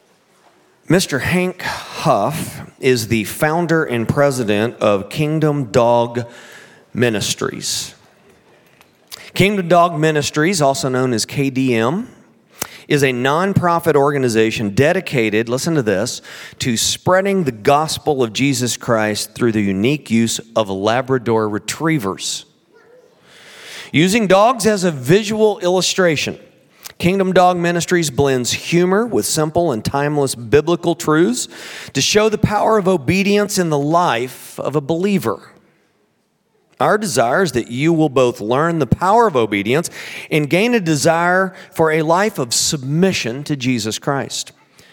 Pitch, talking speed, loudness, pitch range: 150 Hz, 125 wpm, -16 LUFS, 125-180 Hz